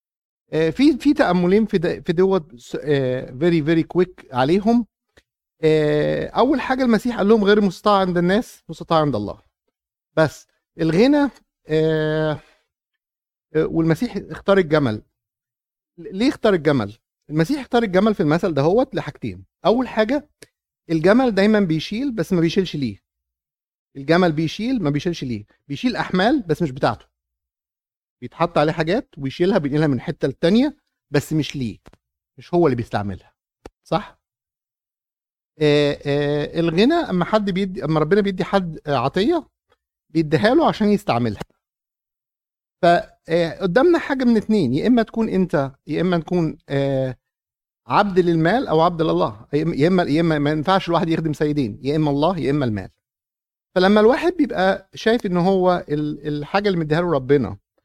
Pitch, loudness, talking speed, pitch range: 165 Hz, -19 LUFS, 135 wpm, 145-195 Hz